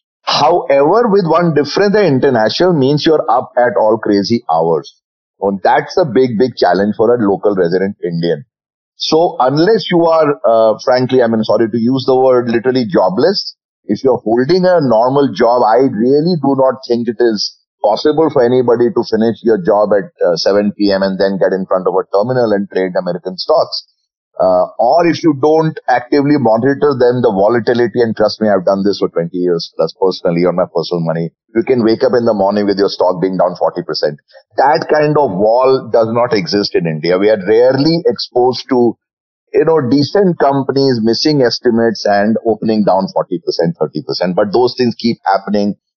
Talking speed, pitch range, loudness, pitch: 190 wpm, 100-145 Hz, -12 LUFS, 120 Hz